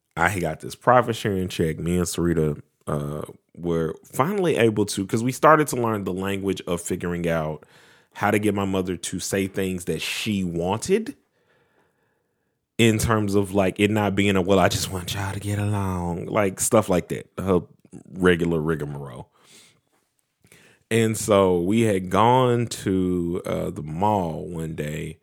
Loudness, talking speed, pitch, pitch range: -23 LUFS, 165 wpm, 95 Hz, 85-105 Hz